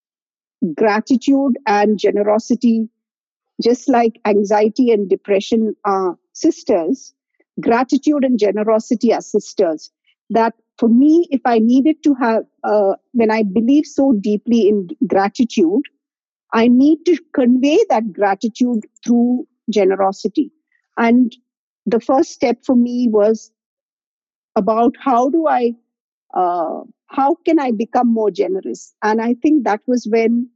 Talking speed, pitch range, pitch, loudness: 125 wpm, 220-275 Hz, 240 Hz, -16 LUFS